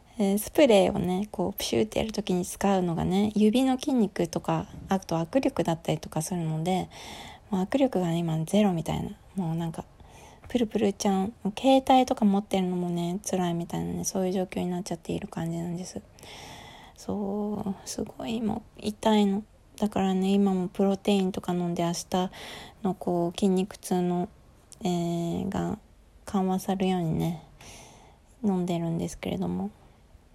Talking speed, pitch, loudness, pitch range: 325 characters per minute, 190 Hz, -28 LUFS, 175-205 Hz